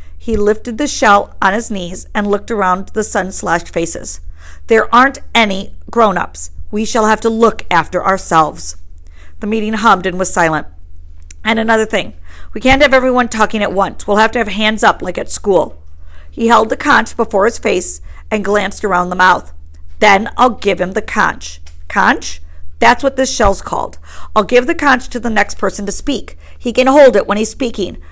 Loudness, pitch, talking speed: -13 LUFS, 200 Hz, 195 wpm